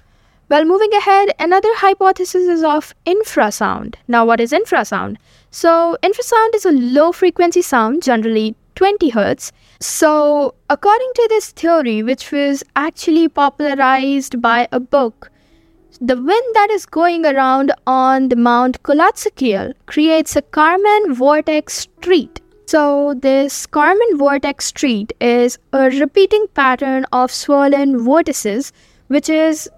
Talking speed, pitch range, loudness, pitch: 125 wpm, 265-360 Hz, -14 LUFS, 295 Hz